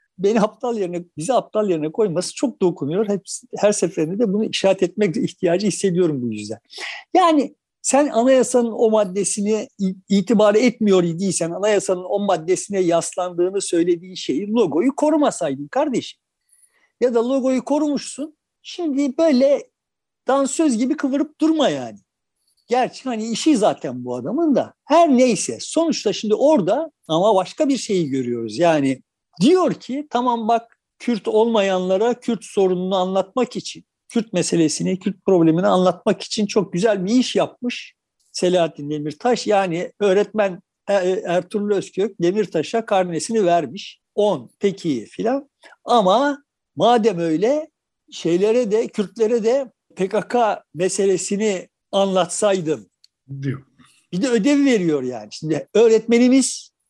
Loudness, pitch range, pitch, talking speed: -19 LUFS, 180-250 Hz, 210 Hz, 125 wpm